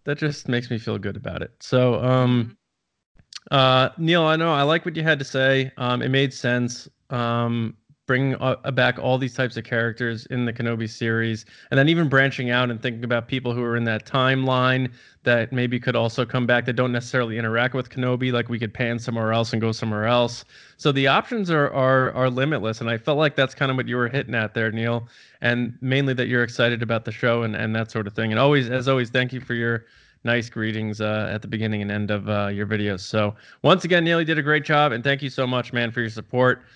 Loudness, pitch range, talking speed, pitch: -22 LUFS, 115-135 Hz, 240 wpm, 125 Hz